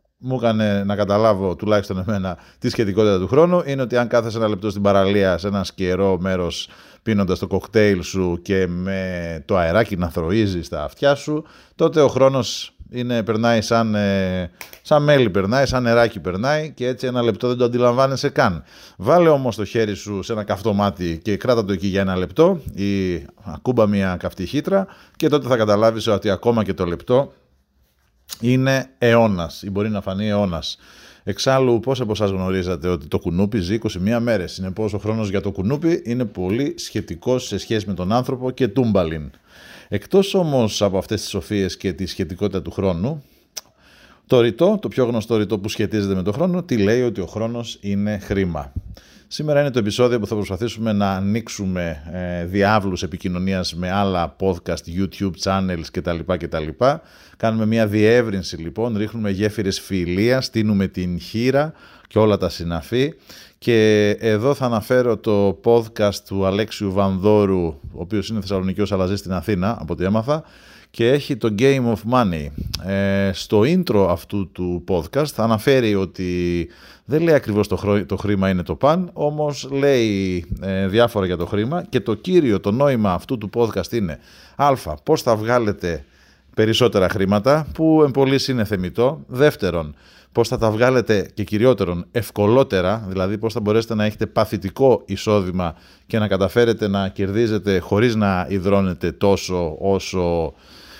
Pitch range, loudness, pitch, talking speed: 95-120 Hz, -20 LUFS, 105 Hz, 165 wpm